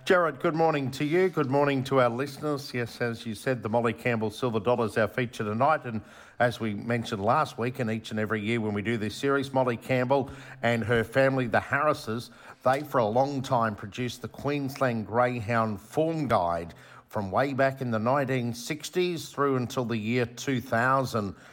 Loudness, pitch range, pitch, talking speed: -28 LUFS, 115-140 Hz, 125 Hz, 190 wpm